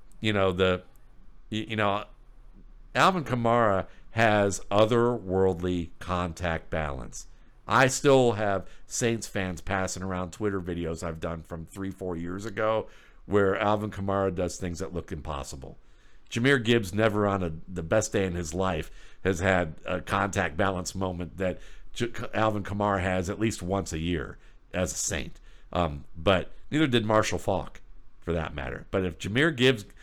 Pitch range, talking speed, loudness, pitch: 90-110 Hz, 155 wpm, -28 LUFS, 95 Hz